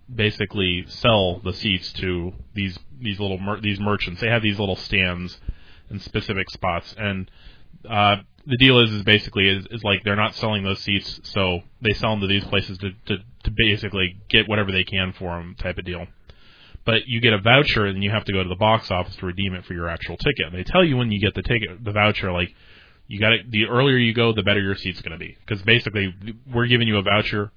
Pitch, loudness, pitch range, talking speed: 100 Hz, -21 LUFS, 95-110 Hz, 235 wpm